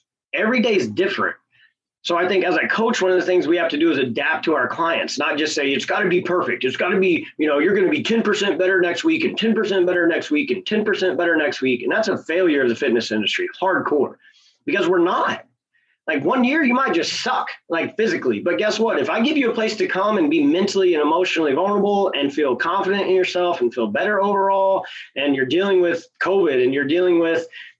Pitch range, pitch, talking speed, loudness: 175-260 Hz, 195 Hz, 245 wpm, -19 LUFS